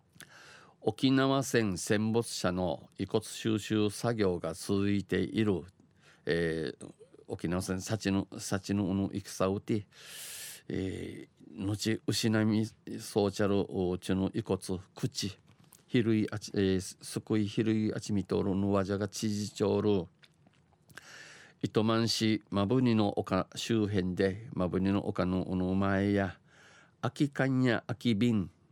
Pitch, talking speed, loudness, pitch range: 100 Hz, 190 characters per minute, -32 LUFS, 95-110 Hz